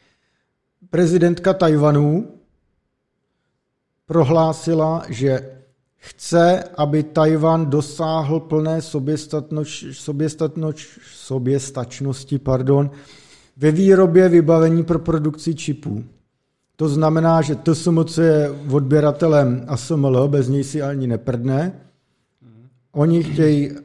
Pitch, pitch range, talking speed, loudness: 150 Hz, 135-165 Hz, 90 wpm, -18 LUFS